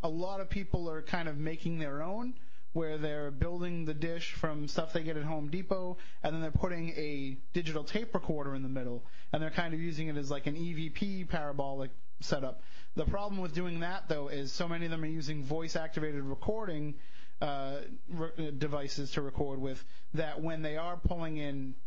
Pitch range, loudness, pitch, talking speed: 145-170 Hz, -38 LUFS, 160 Hz, 200 wpm